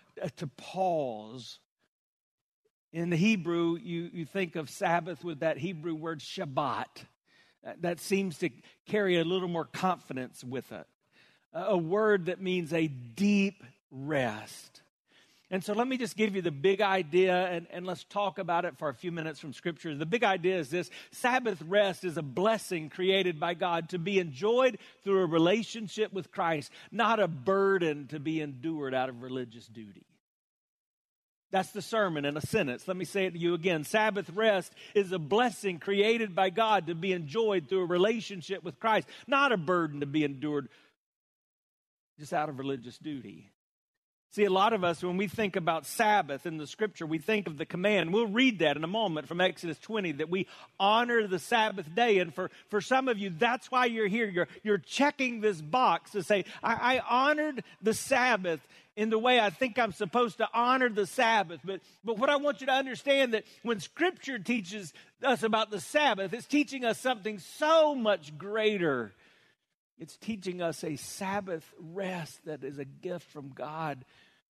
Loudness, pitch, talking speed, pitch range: -30 LUFS, 185 Hz, 180 wpm, 165-215 Hz